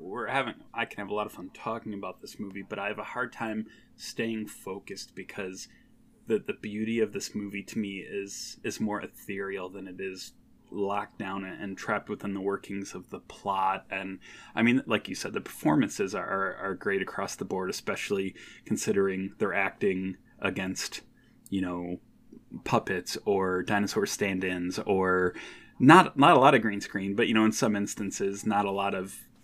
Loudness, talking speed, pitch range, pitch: -29 LUFS, 185 wpm, 95-110 Hz, 100 Hz